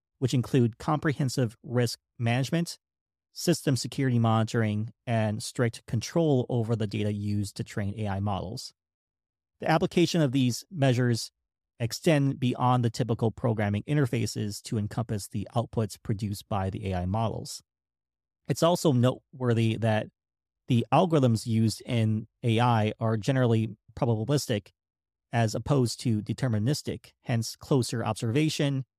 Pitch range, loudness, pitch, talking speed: 105-130 Hz, -28 LUFS, 115 Hz, 120 wpm